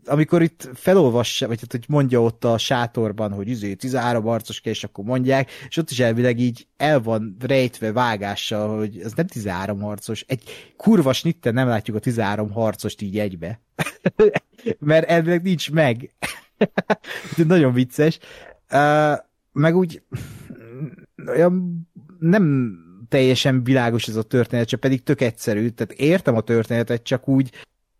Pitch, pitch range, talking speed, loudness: 125 Hz, 115-150 Hz, 140 wpm, -20 LUFS